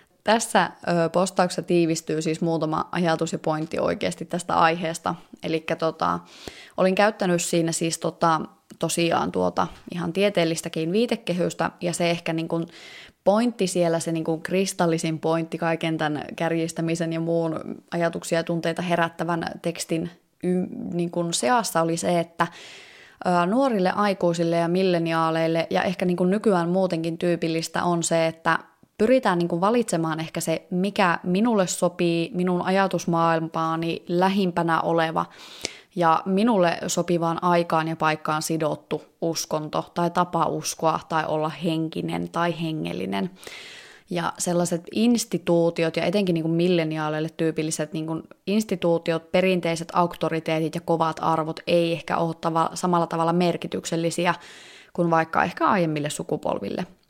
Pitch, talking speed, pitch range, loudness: 170 Hz, 125 wpm, 165-180 Hz, -24 LUFS